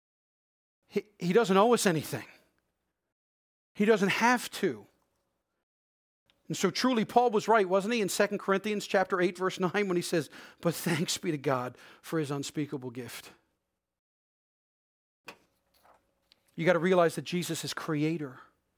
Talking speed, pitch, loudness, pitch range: 140 wpm, 180 Hz, -29 LUFS, 150-200 Hz